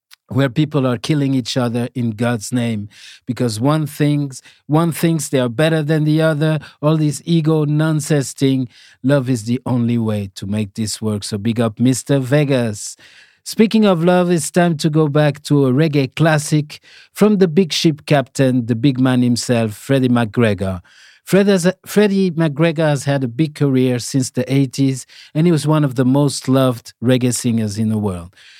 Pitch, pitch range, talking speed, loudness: 135 Hz, 120-155 Hz, 180 wpm, -17 LUFS